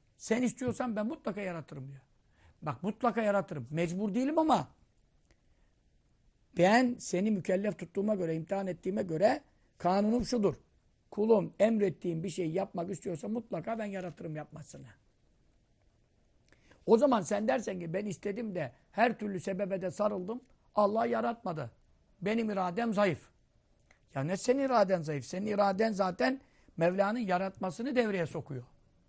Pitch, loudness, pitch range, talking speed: 195 Hz, -32 LUFS, 170-220 Hz, 125 wpm